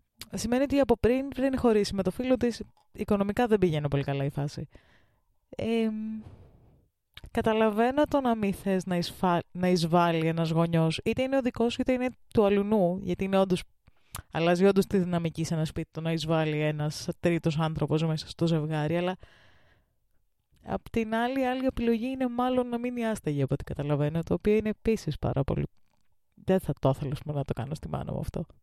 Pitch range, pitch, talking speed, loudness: 160-230 Hz, 185 Hz, 180 wpm, -28 LUFS